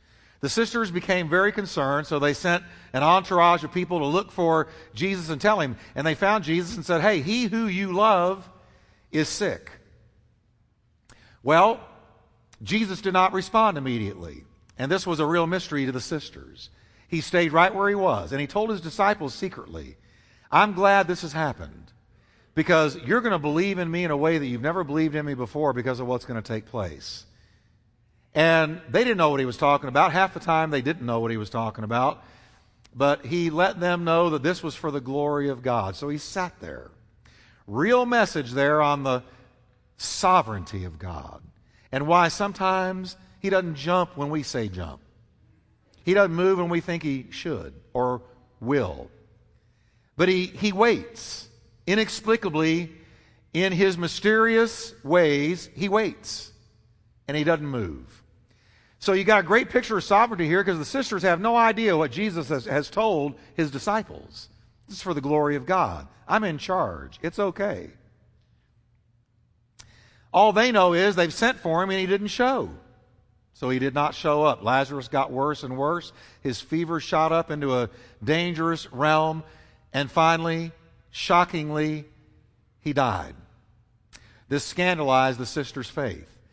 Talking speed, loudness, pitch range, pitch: 170 wpm, -24 LUFS, 115-180 Hz, 150 Hz